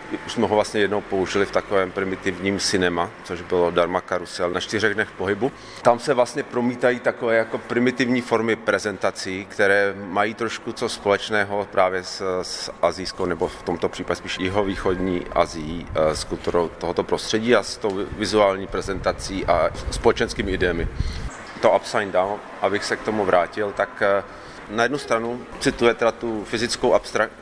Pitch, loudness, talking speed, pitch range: 100 Hz, -22 LUFS, 160 wpm, 90-115 Hz